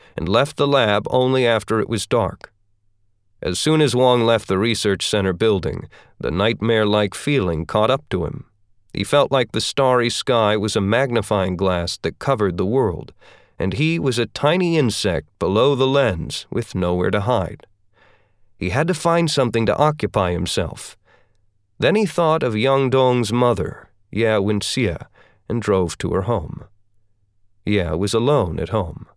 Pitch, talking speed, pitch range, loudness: 110 Hz, 165 wpm, 100-130 Hz, -19 LUFS